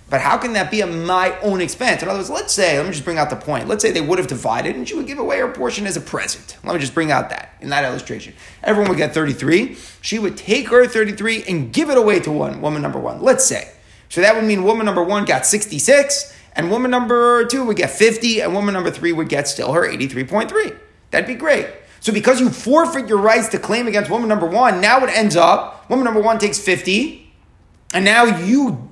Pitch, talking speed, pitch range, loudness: 220 Hz, 245 wpm, 190-245 Hz, -17 LUFS